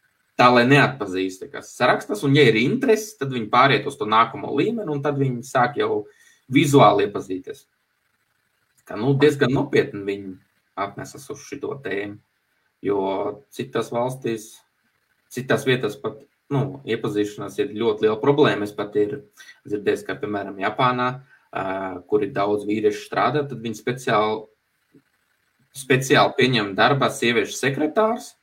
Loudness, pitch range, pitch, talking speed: -21 LUFS, 105-150 Hz, 125 Hz, 135 wpm